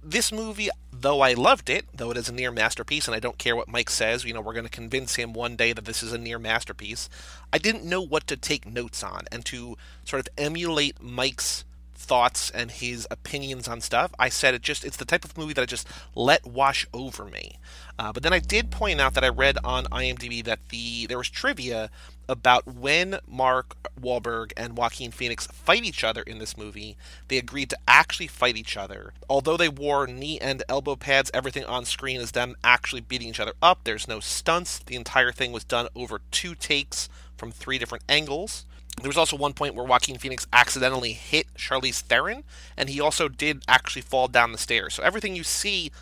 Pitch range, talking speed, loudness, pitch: 115-140 Hz, 215 wpm, -25 LUFS, 125 Hz